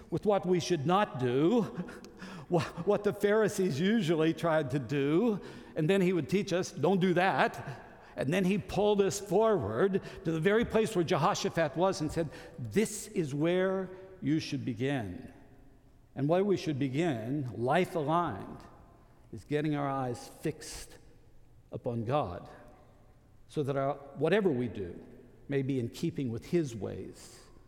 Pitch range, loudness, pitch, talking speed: 135-185 Hz, -31 LUFS, 160 Hz, 150 wpm